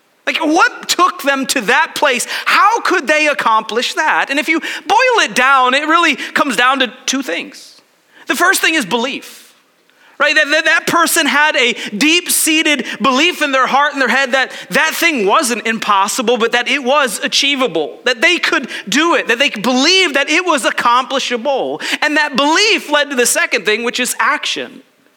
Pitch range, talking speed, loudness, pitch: 255-320 Hz, 190 wpm, -12 LUFS, 285 Hz